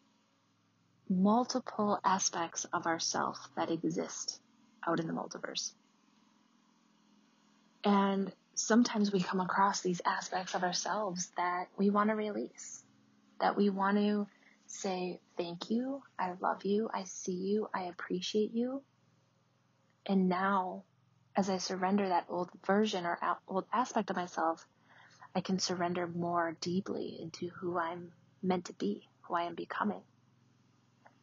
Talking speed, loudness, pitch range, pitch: 130 wpm, -34 LUFS, 180-215 Hz, 190 Hz